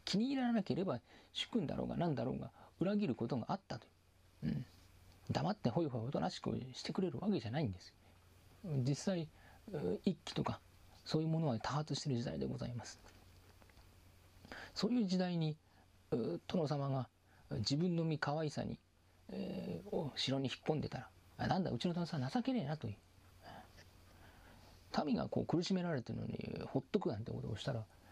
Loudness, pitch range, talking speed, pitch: -40 LUFS, 95-155 Hz, 345 characters per minute, 120 Hz